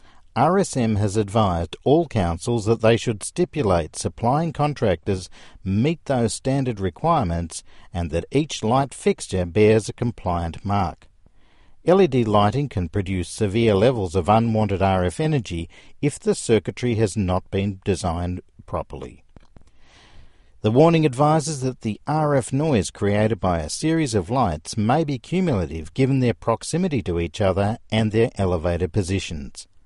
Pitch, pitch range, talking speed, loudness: 105 Hz, 90-130 Hz, 135 wpm, -22 LUFS